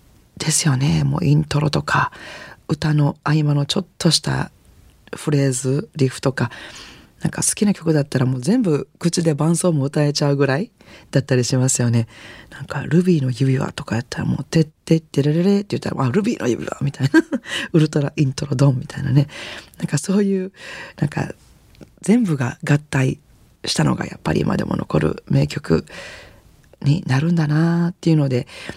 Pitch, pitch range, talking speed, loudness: 150 Hz, 135-170 Hz, 350 characters per minute, -19 LUFS